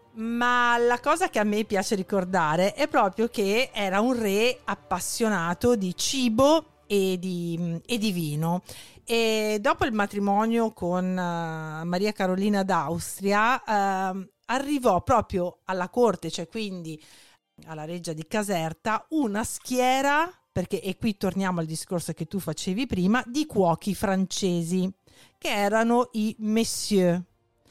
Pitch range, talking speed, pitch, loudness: 180-230 Hz, 130 wpm, 200 Hz, -25 LUFS